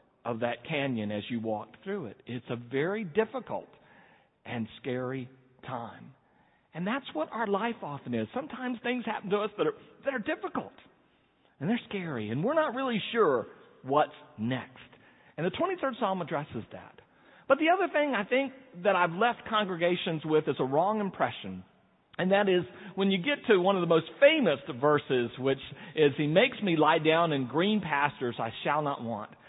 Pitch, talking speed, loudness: 180 Hz, 185 wpm, -29 LUFS